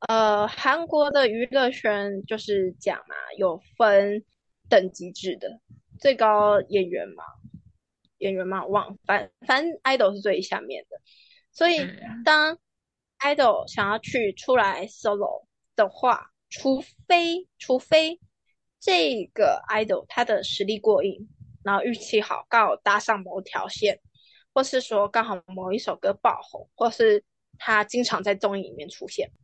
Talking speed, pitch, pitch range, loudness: 220 characters per minute, 220 Hz, 200-275 Hz, -24 LUFS